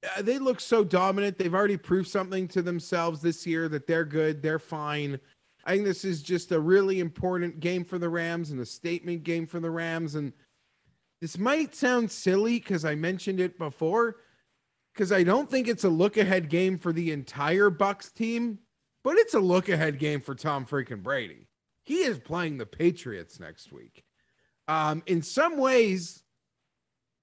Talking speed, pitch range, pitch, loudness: 180 wpm, 160-200 Hz, 175 Hz, -27 LUFS